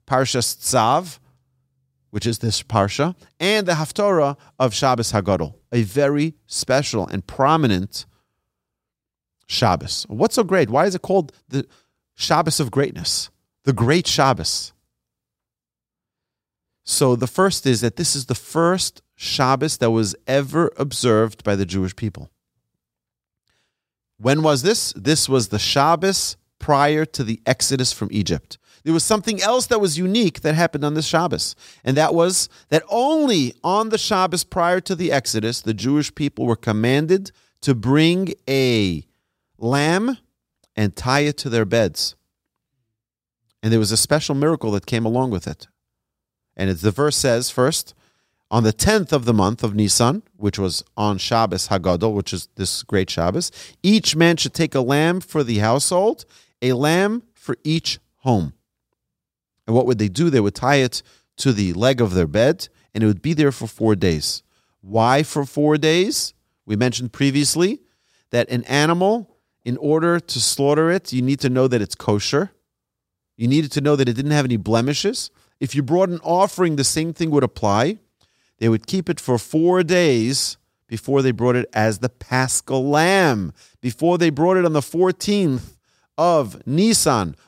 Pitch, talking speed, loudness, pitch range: 135 Hz, 165 wpm, -19 LUFS, 110-160 Hz